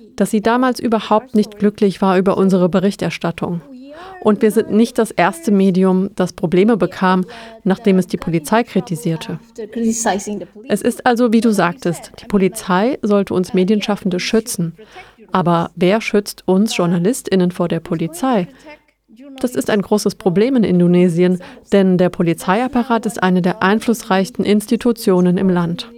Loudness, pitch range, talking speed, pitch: -16 LUFS, 180-225 Hz, 145 wpm, 200 Hz